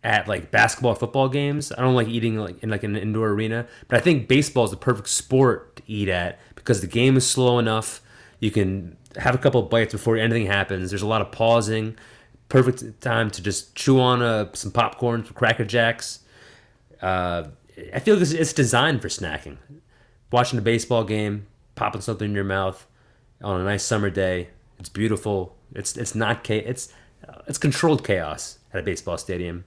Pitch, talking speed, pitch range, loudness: 115 Hz, 190 wpm, 100-120 Hz, -22 LUFS